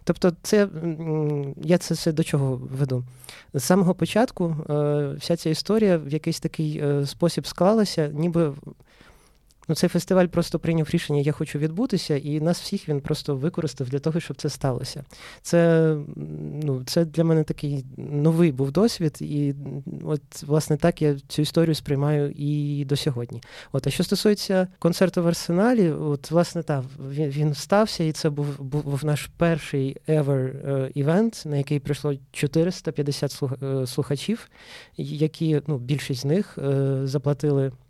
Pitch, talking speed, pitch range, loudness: 150 Hz, 155 wpm, 140-170 Hz, -24 LUFS